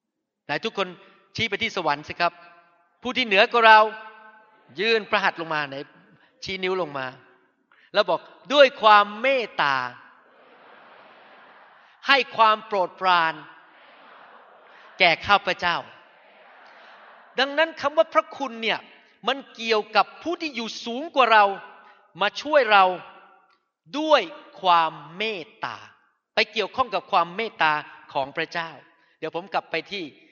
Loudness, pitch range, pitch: -22 LUFS, 170-225 Hz, 200 Hz